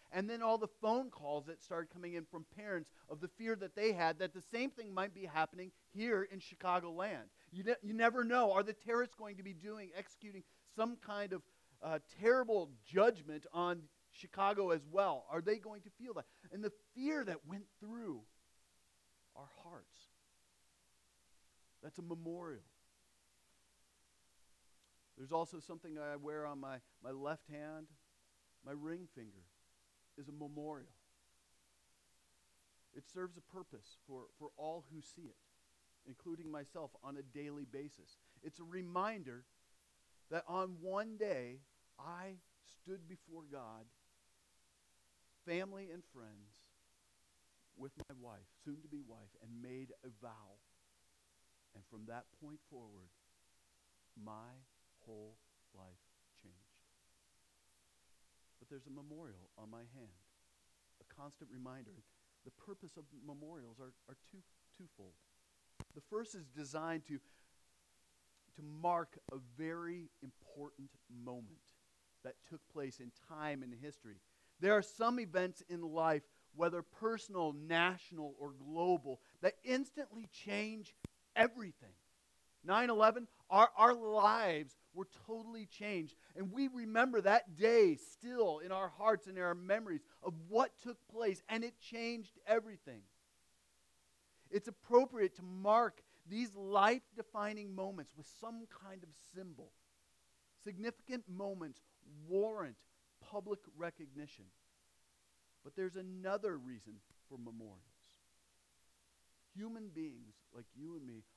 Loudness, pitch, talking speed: -39 LUFS, 155 Hz, 130 wpm